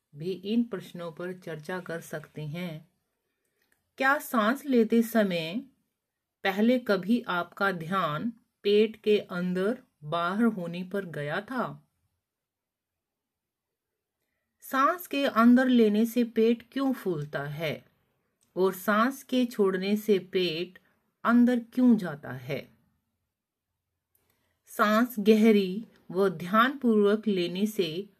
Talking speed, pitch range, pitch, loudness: 105 wpm, 170-230 Hz, 200 Hz, -27 LUFS